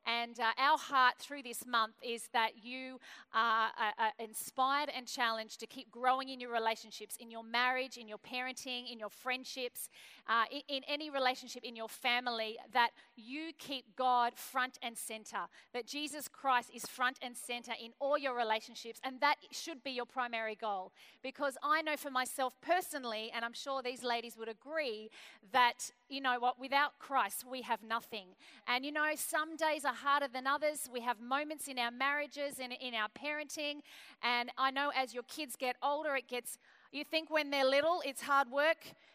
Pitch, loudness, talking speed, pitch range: 255 Hz, -36 LUFS, 190 wpm, 235-280 Hz